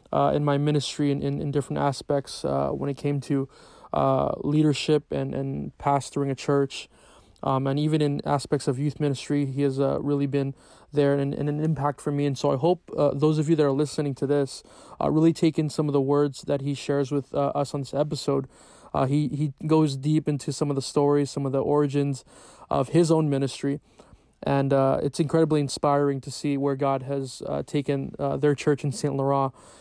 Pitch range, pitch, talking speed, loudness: 140-150 Hz, 145 Hz, 215 wpm, -25 LUFS